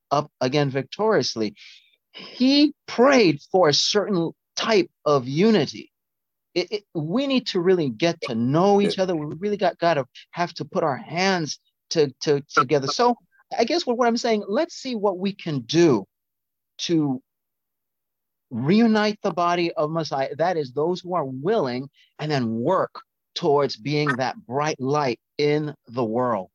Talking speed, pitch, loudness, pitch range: 160 wpm, 165 Hz, -22 LUFS, 140-205 Hz